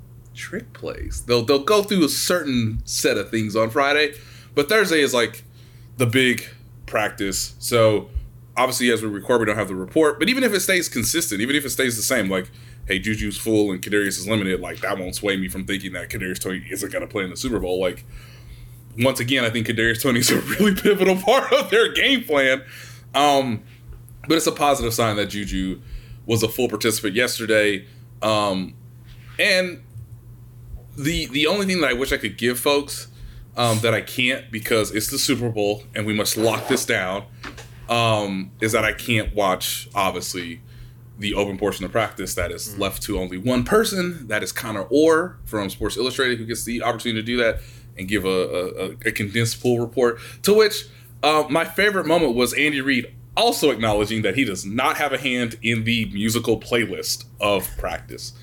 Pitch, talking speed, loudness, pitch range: 120 Hz, 195 wpm, -21 LUFS, 110-130 Hz